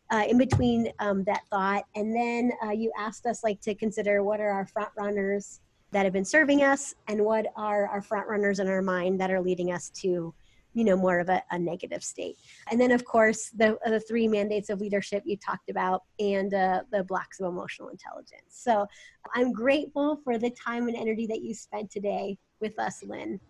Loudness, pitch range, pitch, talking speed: -28 LUFS, 195-225 Hz, 210 Hz, 210 wpm